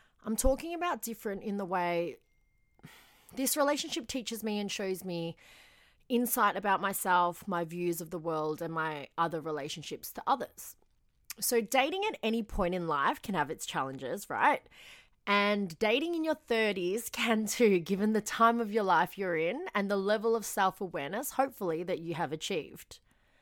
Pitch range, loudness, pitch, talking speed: 175-230 Hz, -32 LUFS, 205 Hz, 170 wpm